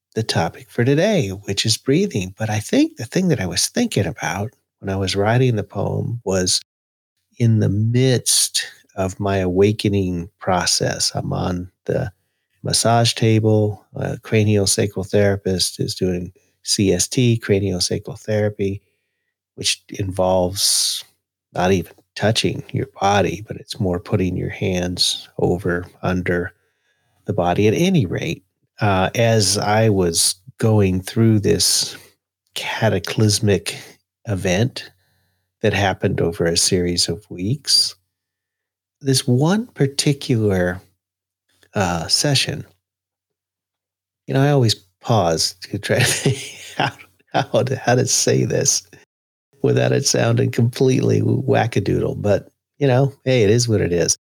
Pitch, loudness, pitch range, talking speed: 105 Hz, -19 LUFS, 95-120 Hz, 125 wpm